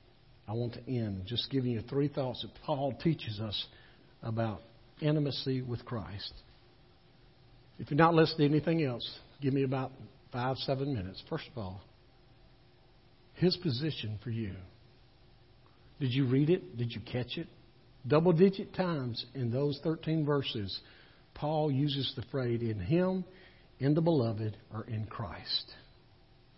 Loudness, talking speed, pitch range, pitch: -33 LUFS, 145 wpm, 115-145 Hz, 125 Hz